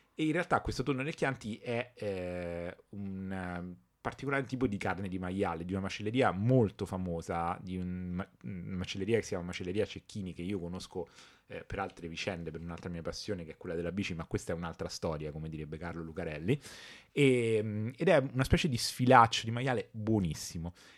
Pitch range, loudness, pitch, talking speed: 85-120 Hz, -34 LUFS, 95 Hz, 185 wpm